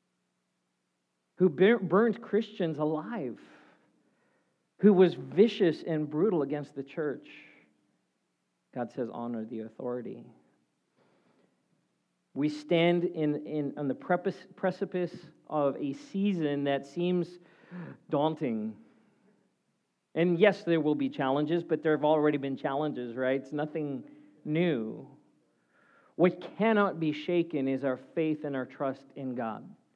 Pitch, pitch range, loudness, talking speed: 155 Hz, 135-180 Hz, -30 LUFS, 115 wpm